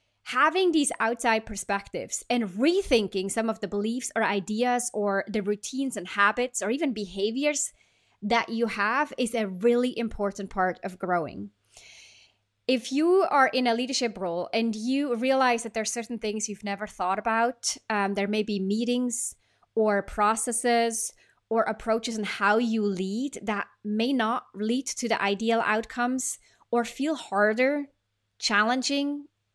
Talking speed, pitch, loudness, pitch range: 150 wpm, 225 Hz, -27 LUFS, 205-245 Hz